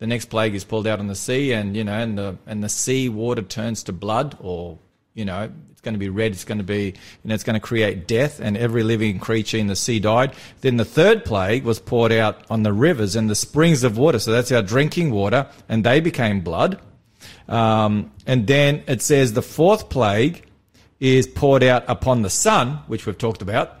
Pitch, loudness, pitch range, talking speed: 115 Hz, -20 LUFS, 105-130 Hz, 230 wpm